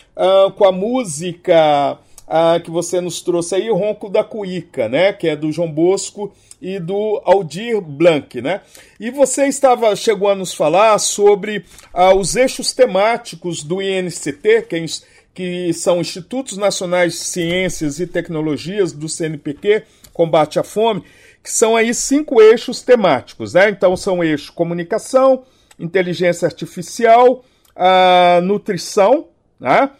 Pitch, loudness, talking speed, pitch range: 190 Hz, -15 LUFS, 140 wpm, 175-220 Hz